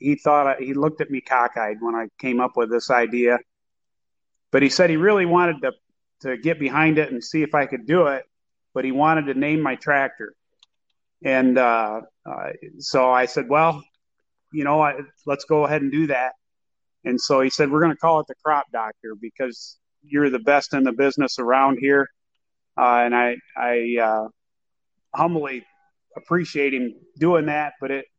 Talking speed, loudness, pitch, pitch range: 190 wpm, -21 LUFS, 140 Hz, 125-155 Hz